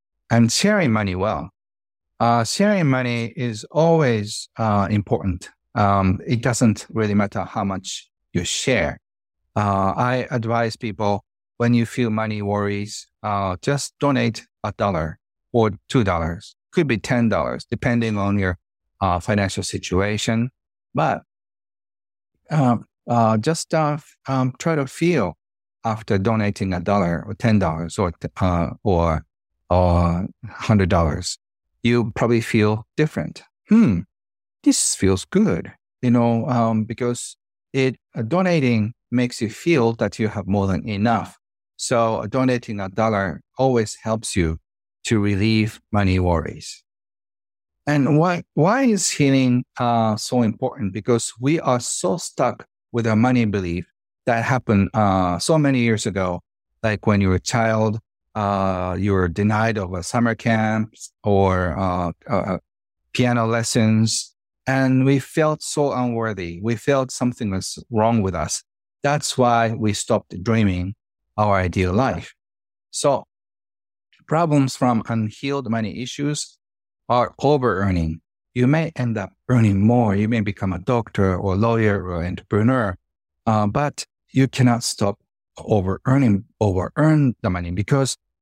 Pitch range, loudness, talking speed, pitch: 95-125 Hz, -21 LUFS, 140 wpm, 110 Hz